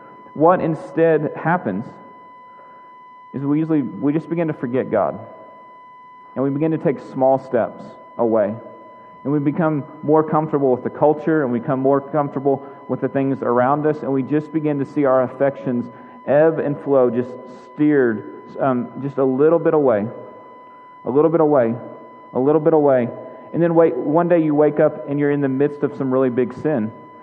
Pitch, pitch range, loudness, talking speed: 145 Hz, 135-160 Hz, -19 LUFS, 185 wpm